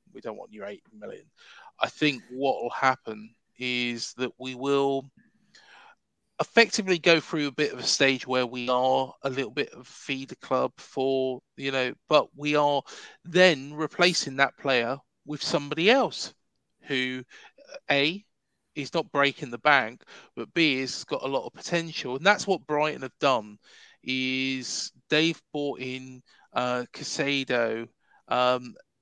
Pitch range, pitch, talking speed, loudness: 130-155 Hz, 135 Hz, 150 wpm, -26 LUFS